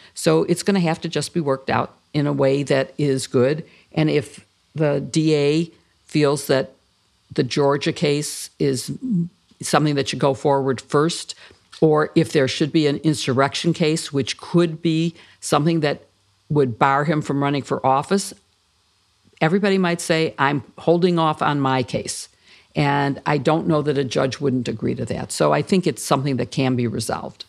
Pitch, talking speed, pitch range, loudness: 145 Hz, 175 wpm, 135-160 Hz, -20 LUFS